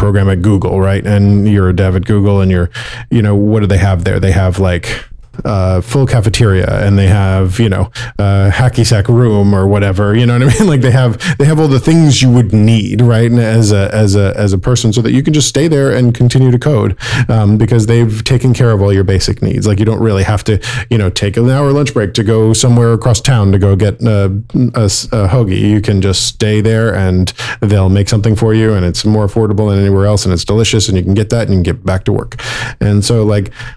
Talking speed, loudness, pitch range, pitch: 255 wpm, -10 LUFS, 100-120 Hz, 110 Hz